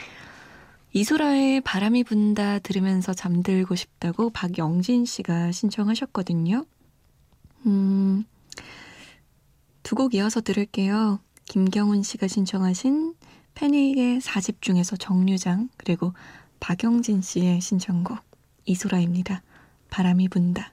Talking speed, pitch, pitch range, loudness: 235 characters per minute, 200 Hz, 185-225 Hz, -24 LUFS